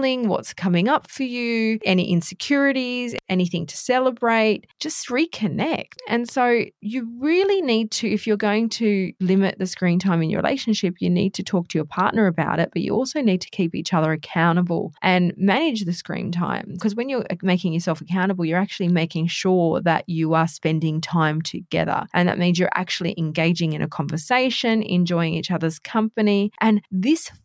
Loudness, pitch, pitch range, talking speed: -21 LUFS, 185 Hz, 170-225 Hz, 180 wpm